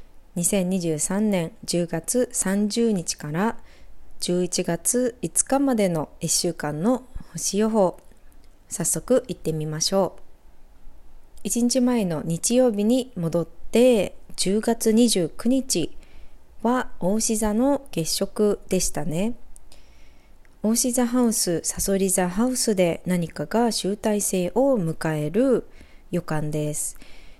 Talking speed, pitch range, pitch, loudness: 170 characters per minute, 165-230 Hz, 195 Hz, -23 LUFS